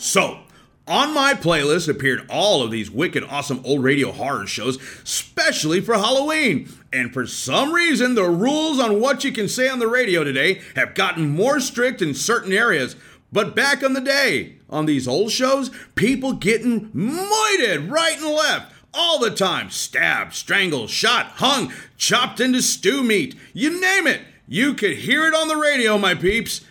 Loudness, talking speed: -19 LUFS, 175 wpm